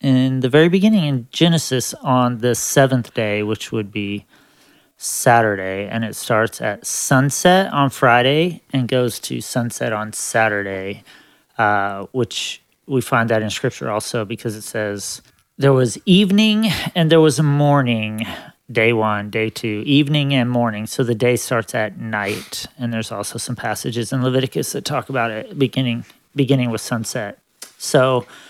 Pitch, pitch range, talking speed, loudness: 125 Hz, 110-140 Hz, 160 wpm, -18 LUFS